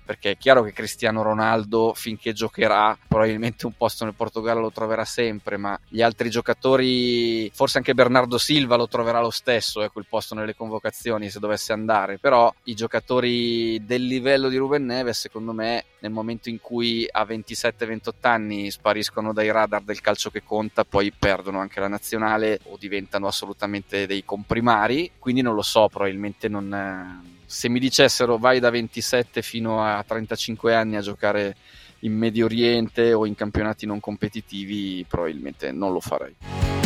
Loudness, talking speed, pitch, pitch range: -23 LUFS, 165 wpm, 110 Hz, 105-115 Hz